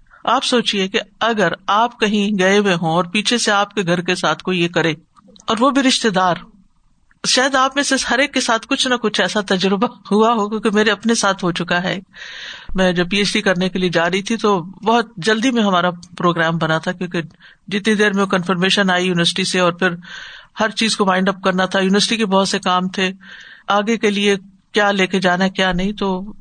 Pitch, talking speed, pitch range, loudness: 200 Hz, 225 wpm, 185-220 Hz, -17 LUFS